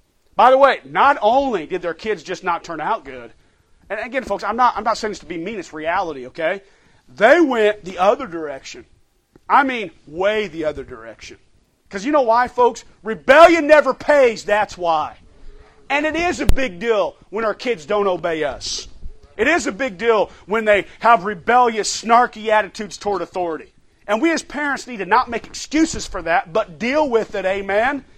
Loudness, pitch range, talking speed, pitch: -18 LUFS, 190-255 Hz, 190 wpm, 215 Hz